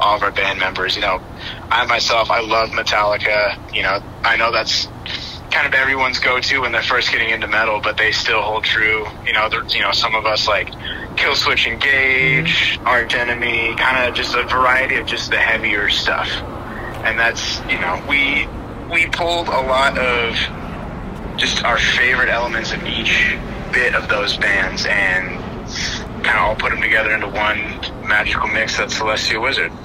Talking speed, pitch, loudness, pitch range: 180 wpm, 110 Hz, -16 LUFS, 105-120 Hz